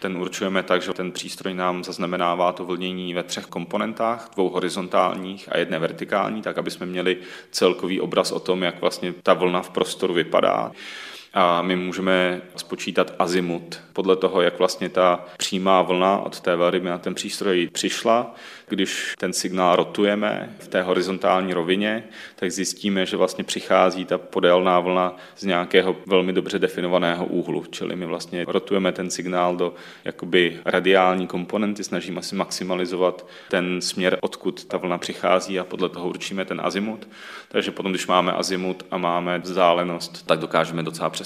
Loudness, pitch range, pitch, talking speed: -23 LUFS, 90-95 Hz, 90 Hz, 160 wpm